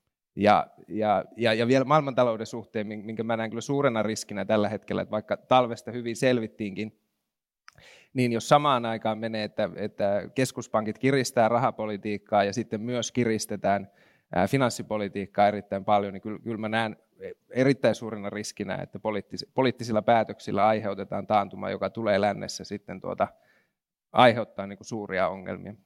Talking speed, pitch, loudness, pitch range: 130 wpm, 110 Hz, -27 LUFS, 105-120 Hz